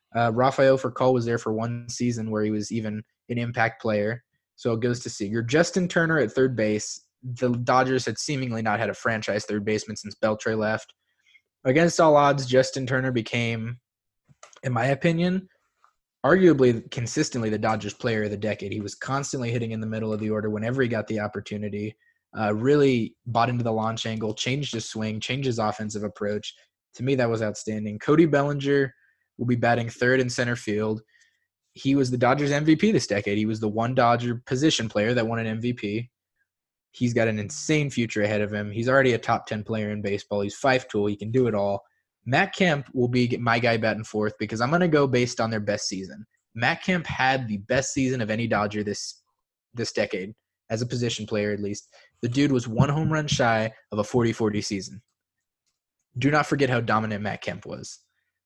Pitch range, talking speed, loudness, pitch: 105-130 Hz, 200 wpm, -25 LUFS, 115 Hz